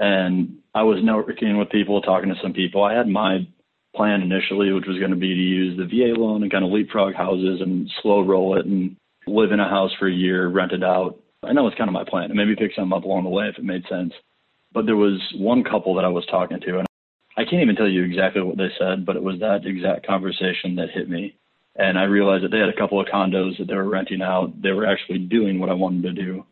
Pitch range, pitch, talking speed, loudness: 95-100 Hz, 95 Hz, 265 wpm, -21 LUFS